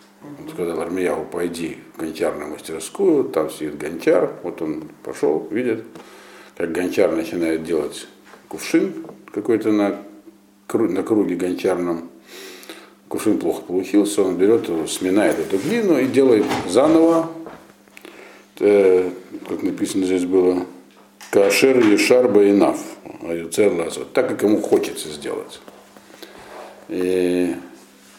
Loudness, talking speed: -19 LUFS, 110 wpm